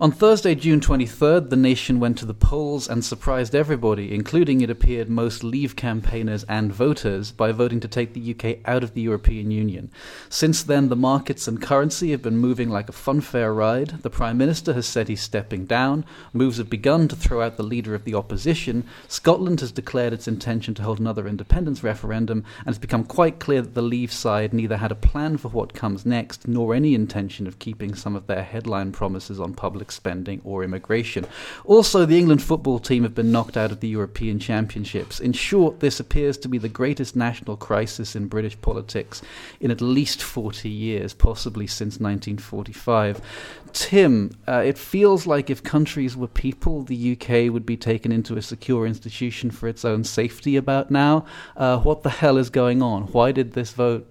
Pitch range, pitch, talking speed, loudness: 110-135 Hz, 120 Hz, 195 wpm, -22 LUFS